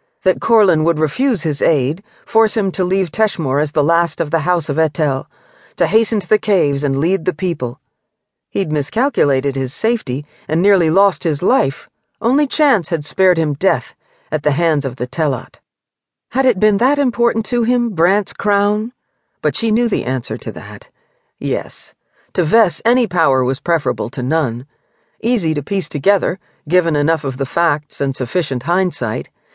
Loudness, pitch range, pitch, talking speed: -16 LUFS, 145-215 Hz, 170 Hz, 175 wpm